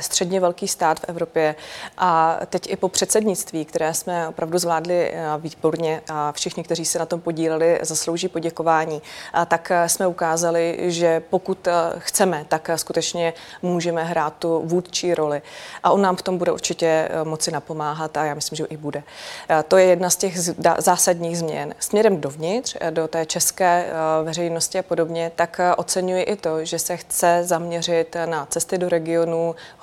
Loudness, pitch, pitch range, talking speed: -21 LUFS, 170 Hz, 160-180 Hz, 165 wpm